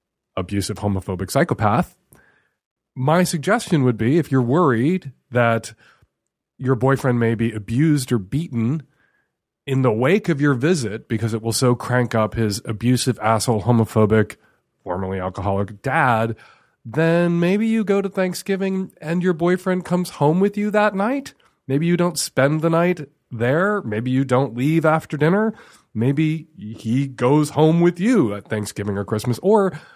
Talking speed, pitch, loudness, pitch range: 150 wpm, 135 Hz, -20 LUFS, 115-170 Hz